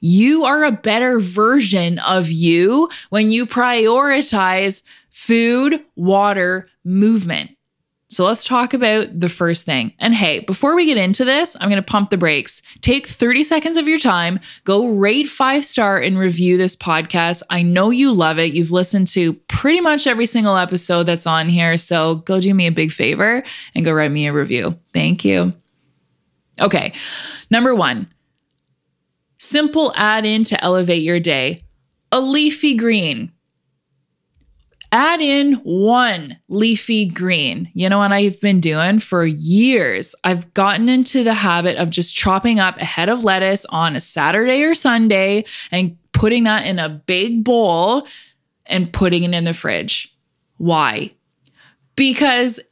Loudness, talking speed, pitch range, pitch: -15 LUFS, 155 wpm, 170-235 Hz, 195 Hz